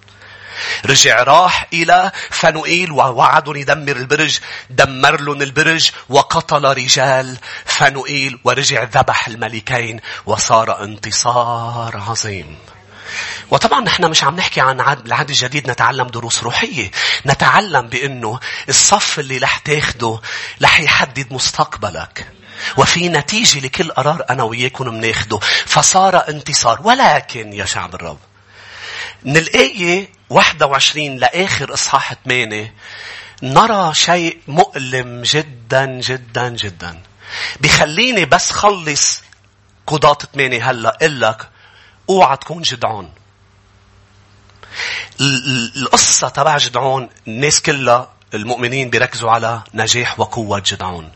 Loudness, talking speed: -13 LUFS, 100 wpm